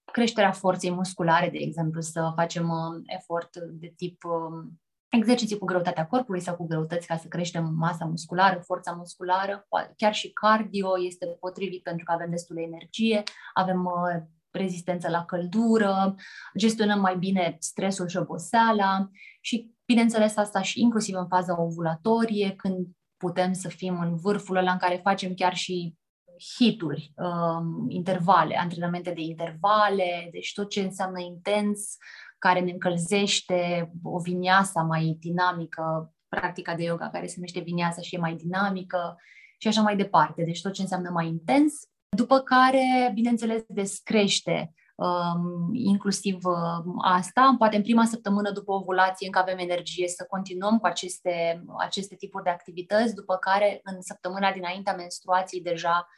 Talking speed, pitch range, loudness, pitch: 145 wpm, 170-200 Hz, -26 LUFS, 180 Hz